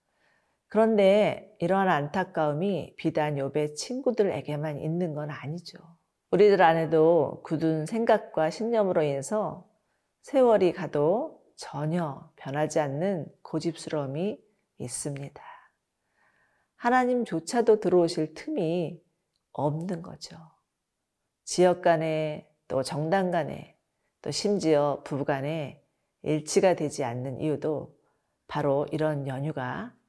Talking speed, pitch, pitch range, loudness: 235 characters per minute, 160 Hz, 150-190 Hz, -27 LUFS